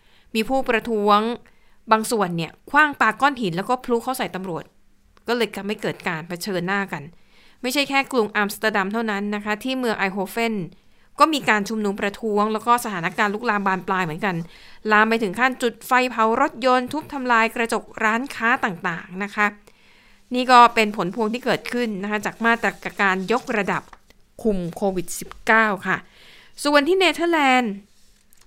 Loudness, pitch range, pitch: -21 LUFS, 200-240 Hz, 220 Hz